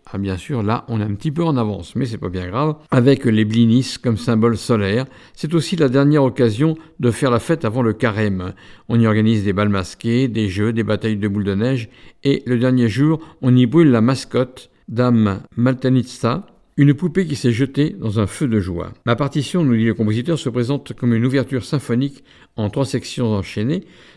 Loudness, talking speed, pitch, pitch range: -18 LUFS, 210 wpm, 120 Hz, 110-140 Hz